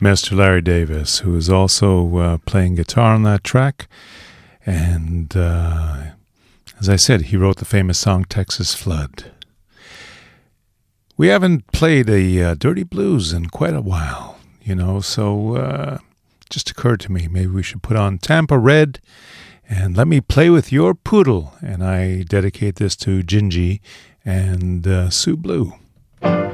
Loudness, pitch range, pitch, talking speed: -17 LUFS, 90-115 Hz, 95 Hz, 150 wpm